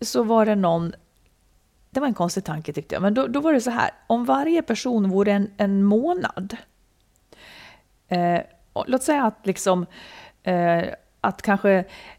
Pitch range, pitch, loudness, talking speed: 185-255 Hz, 205 Hz, -22 LUFS, 165 wpm